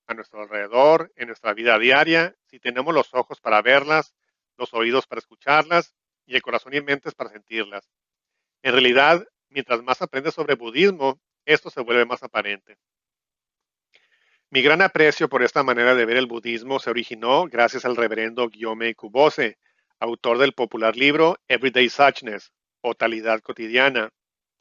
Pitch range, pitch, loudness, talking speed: 115-140 Hz, 125 Hz, -20 LUFS, 150 wpm